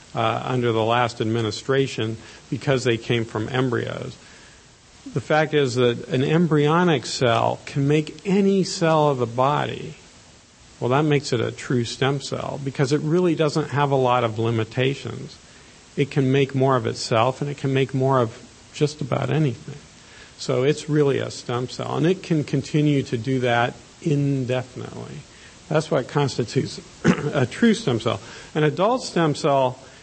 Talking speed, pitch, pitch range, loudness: 160 wpm, 135 Hz, 125-150 Hz, -22 LUFS